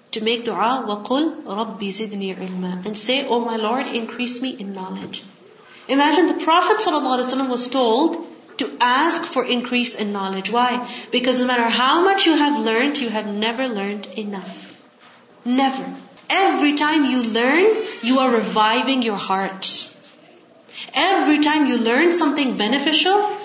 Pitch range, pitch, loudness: 225-300 Hz, 250 Hz, -19 LUFS